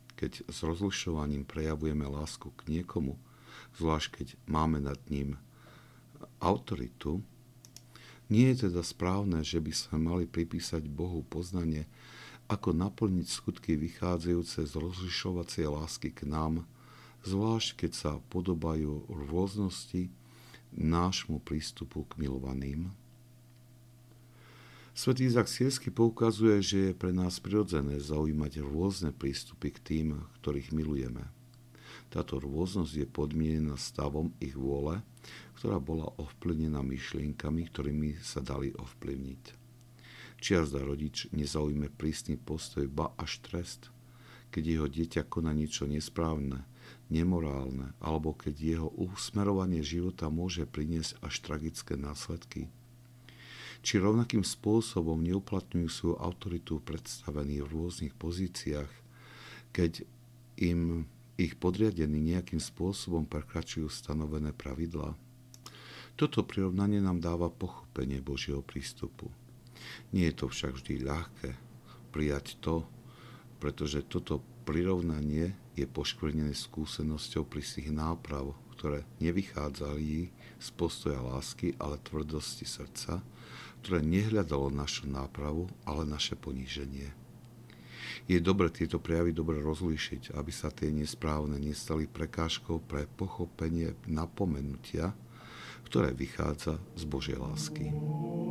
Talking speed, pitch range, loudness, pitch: 105 wpm, 75-95 Hz, -34 LUFS, 80 Hz